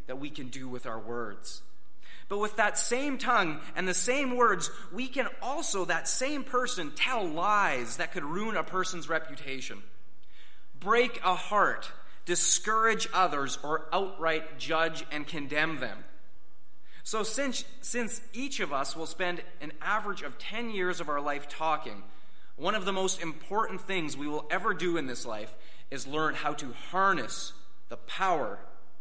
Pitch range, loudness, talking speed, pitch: 145-215 Hz, -30 LUFS, 160 wpm, 175 Hz